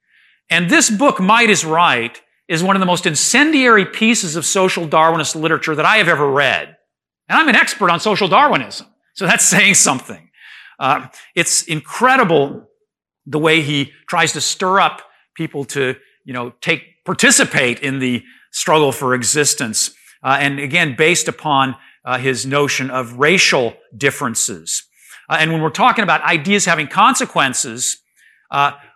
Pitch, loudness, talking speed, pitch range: 160 Hz, -14 LUFS, 155 wpm, 140-190 Hz